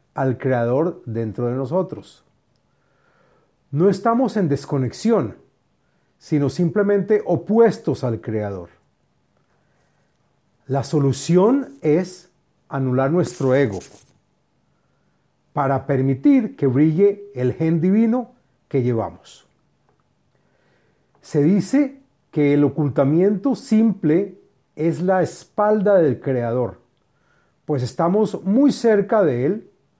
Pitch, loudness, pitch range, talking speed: 155 Hz, -20 LUFS, 135-200 Hz, 90 wpm